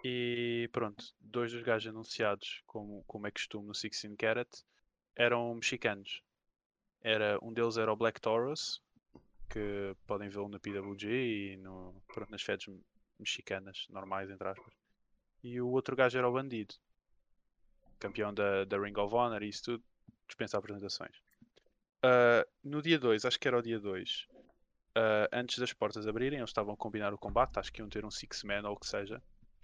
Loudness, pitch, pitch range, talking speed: -35 LUFS, 110 Hz, 100-120 Hz, 175 wpm